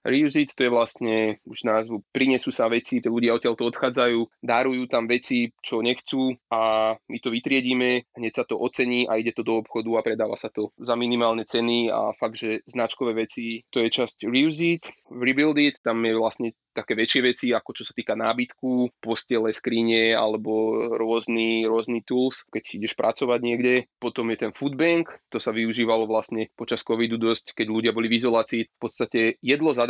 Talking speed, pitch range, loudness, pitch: 185 wpm, 115-125 Hz, -24 LUFS, 115 Hz